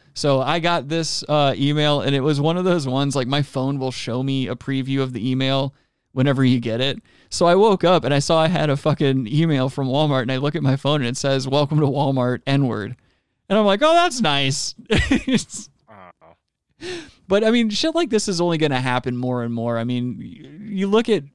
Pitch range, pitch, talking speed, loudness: 130-170 Hz, 140 Hz, 230 wpm, -20 LUFS